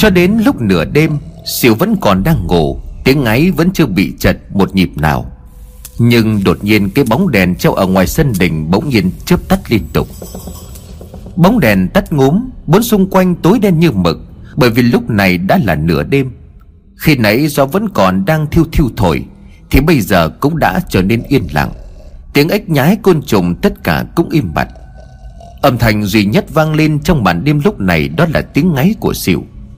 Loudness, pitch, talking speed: -12 LUFS, 130 Hz, 200 wpm